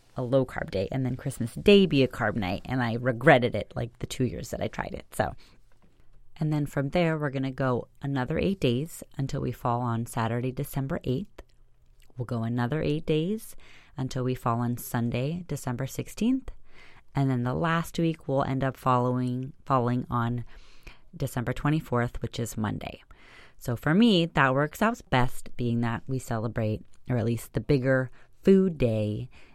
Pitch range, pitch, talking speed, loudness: 120-145 Hz, 130 Hz, 180 wpm, -28 LUFS